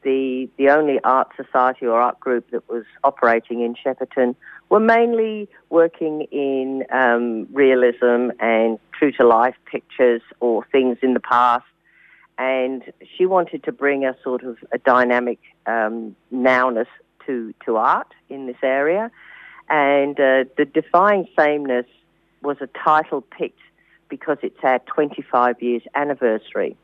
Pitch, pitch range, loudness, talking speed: 130 Hz, 120-145 Hz, -19 LUFS, 140 wpm